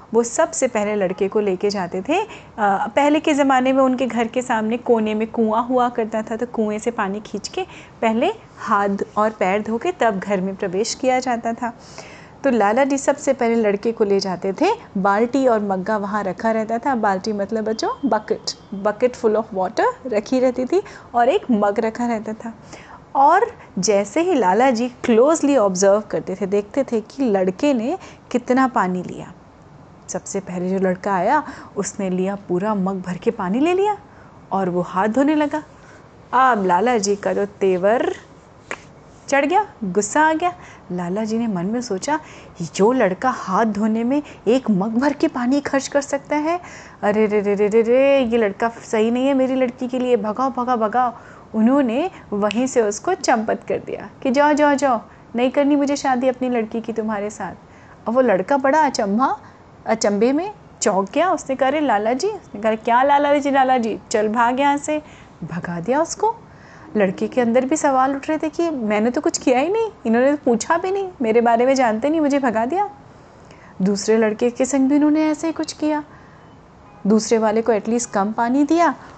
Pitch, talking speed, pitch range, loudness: 235 Hz, 190 wpm, 210-275 Hz, -19 LUFS